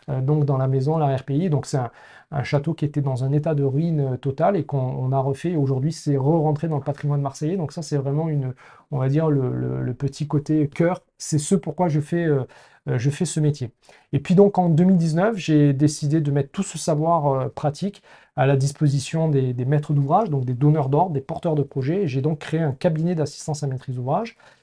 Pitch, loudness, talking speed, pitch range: 150 Hz, -22 LUFS, 230 wpm, 140-160 Hz